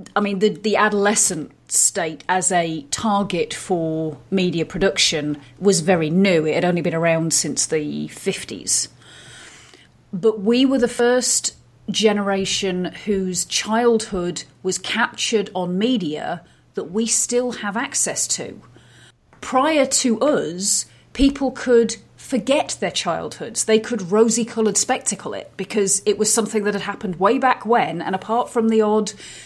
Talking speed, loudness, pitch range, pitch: 145 wpm, -19 LUFS, 180-230 Hz, 205 Hz